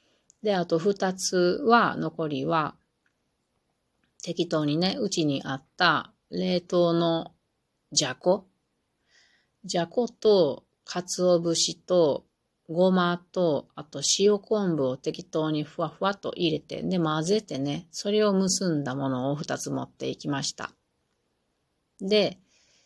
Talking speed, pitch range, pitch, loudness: 200 characters per minute, 155-190 Hz, 175 Hz, -26 LUFS